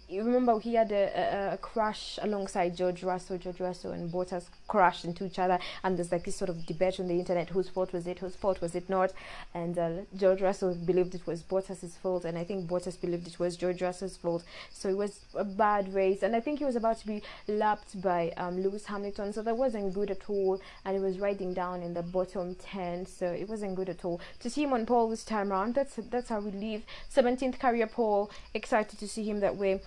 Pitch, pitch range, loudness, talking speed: 190 Hz, 180-210 Hz, -32 LUFS, 240 wpm